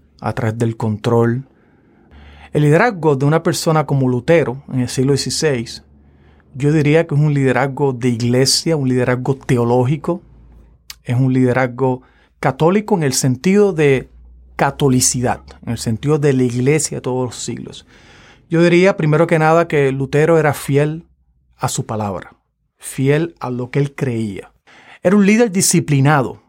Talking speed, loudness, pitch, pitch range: 150 wpm, -16 LUFS, 135 Hz, 120-155 Hz